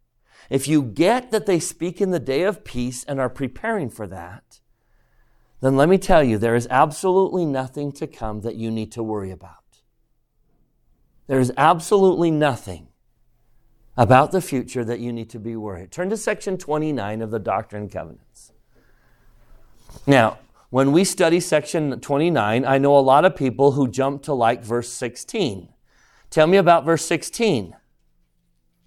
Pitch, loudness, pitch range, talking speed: 130 Hz, -20 LUFS, 115-160 Hz, 160 wpm